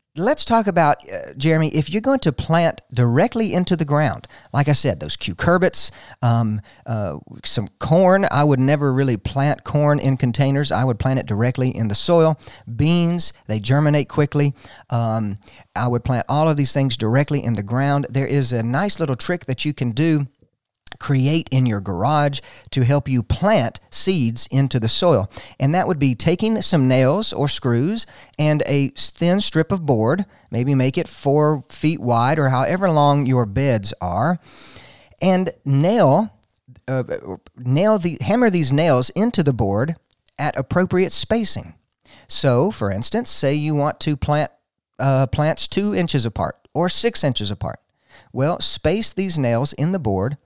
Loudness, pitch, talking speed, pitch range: -19 LUFS, 140 Hz, 170 wpm, 120-160 Hz